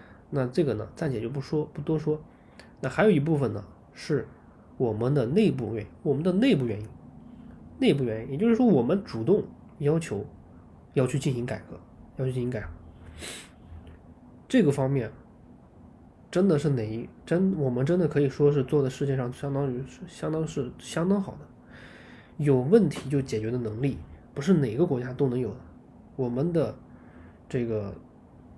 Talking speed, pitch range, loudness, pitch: 250 characters per minute, 115-155 Hz, -27 LUFS, 135 Hz